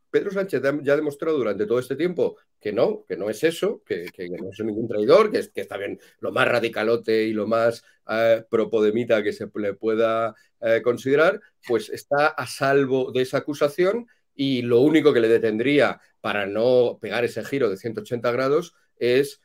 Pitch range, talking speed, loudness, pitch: 115-185 Hz, 190 wpm, -22 LUFS, 135 Hz